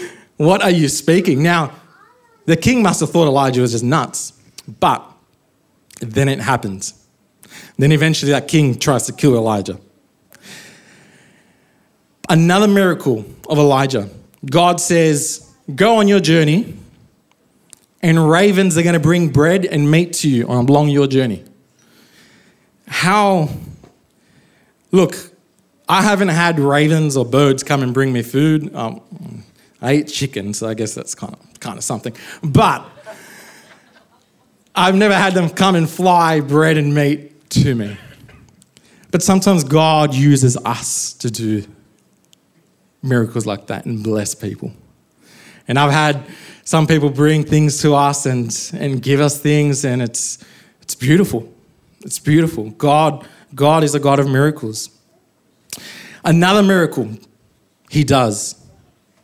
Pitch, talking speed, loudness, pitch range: 150 Hz, 135 wpm, -15 LUFS, 130-170 Hz